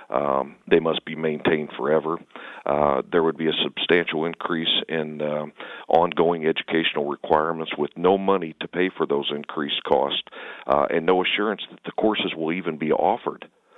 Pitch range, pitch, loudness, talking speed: 80-90 Hz, 80 Hz, -23 LUFS, 165 wpm